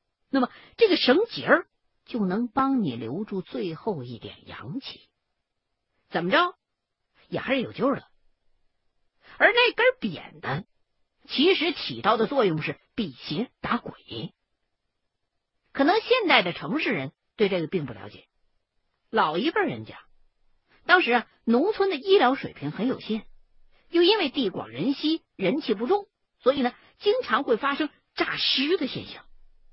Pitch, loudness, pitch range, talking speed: 275 Hz, -25 LUFS, 215-360 Hz, 205 characters per minute